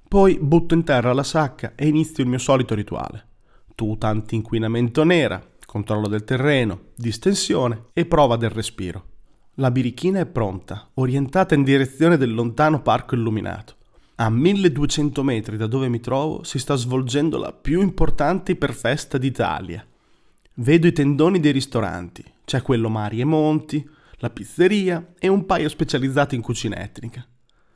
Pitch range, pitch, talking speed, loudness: 115-155 Hz, 135 Hz, 150 wpm, -20 LUFS